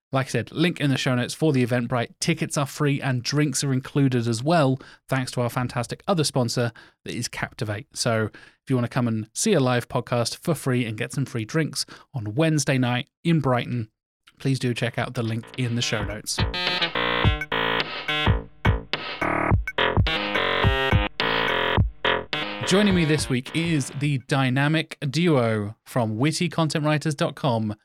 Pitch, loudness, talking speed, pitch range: 130 Hz, -24 LUFS, 155 wpm, 120-150 Hz